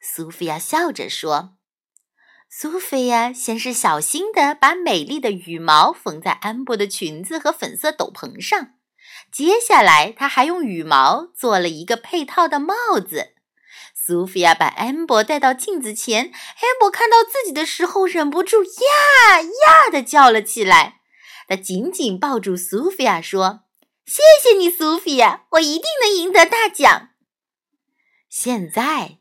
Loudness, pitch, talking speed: -16 LUFS, 290 Hz, 215 characters per minute